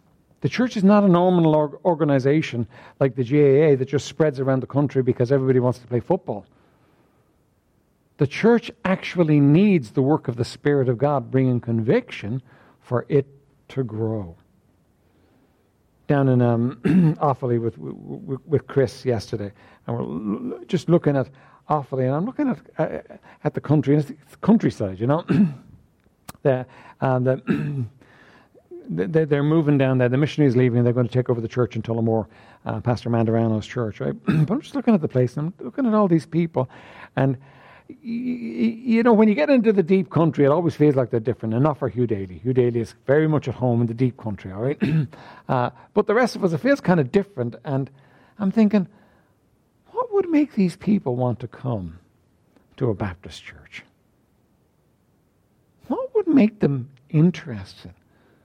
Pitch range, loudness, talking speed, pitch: 120-170 Hz, -21 LUFS, 180 wpm, 135 Hz